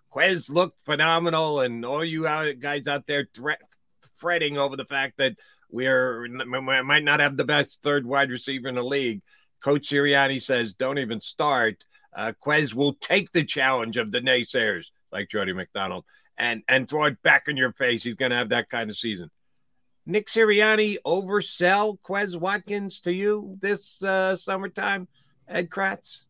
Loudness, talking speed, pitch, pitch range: -24 LUFS, 170 wpm, 145 Hz, 130-190 Hz